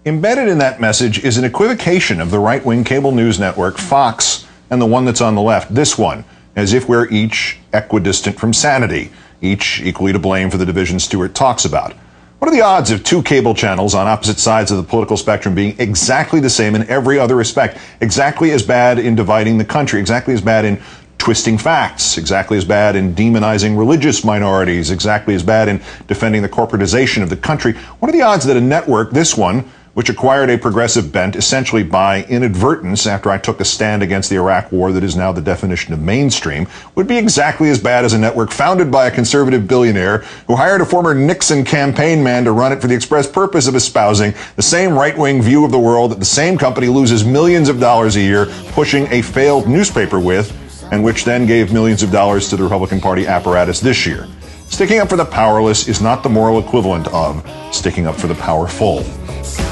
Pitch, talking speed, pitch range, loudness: 110 Hz, 210 wpm, 100-130 Hz, -13 LUFS